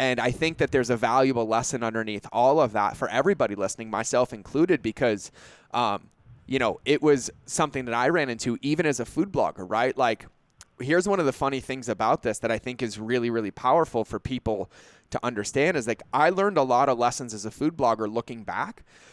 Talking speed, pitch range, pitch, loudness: 215 wpm, 115-135 Hz, 120 Hz, -25 LUFS